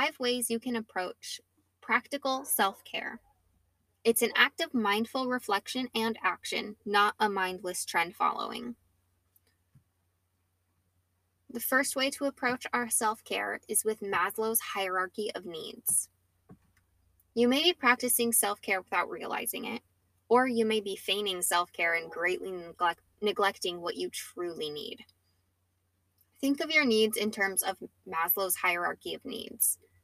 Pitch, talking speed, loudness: 200 Hz, 140 wpm, -30 LUFS